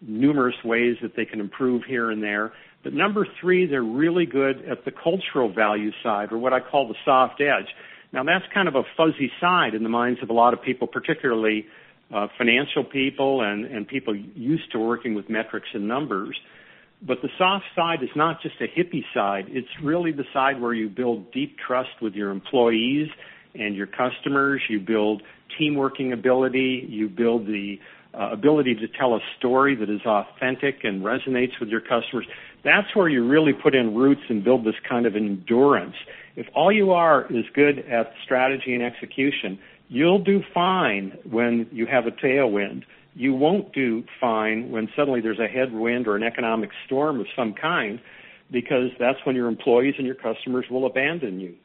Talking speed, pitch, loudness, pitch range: 185 wpm, 125 Hz, -23 LUFS, 110-140 Hz